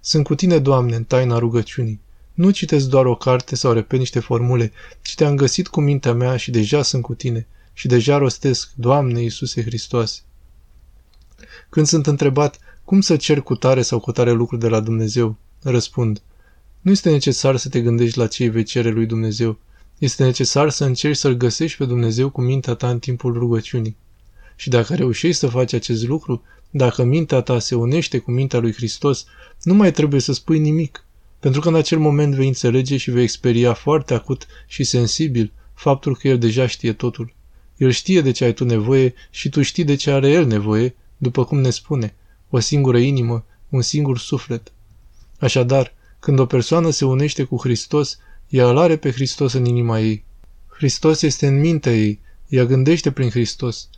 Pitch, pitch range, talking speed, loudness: 125 Hz, 115-140 Hz, 185 wpm, -18 LUFS